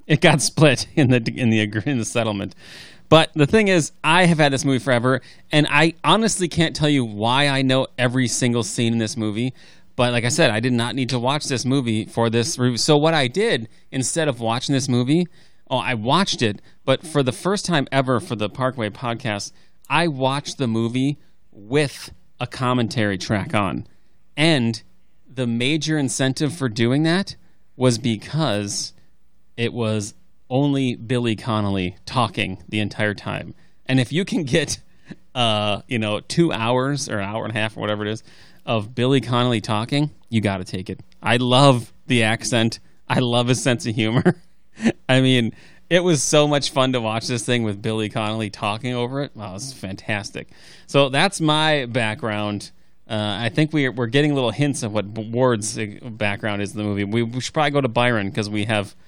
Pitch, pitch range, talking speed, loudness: 125 Hz, 110-145 Hz, 190 wpm, -20 LUFS